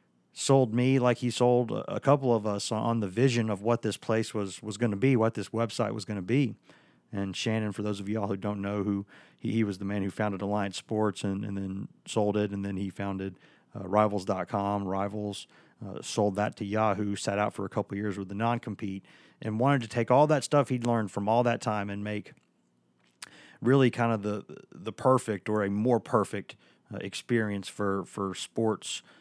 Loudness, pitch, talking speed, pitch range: -29 LUFS, 105 Hz, 205 wpm, 100-115 Hz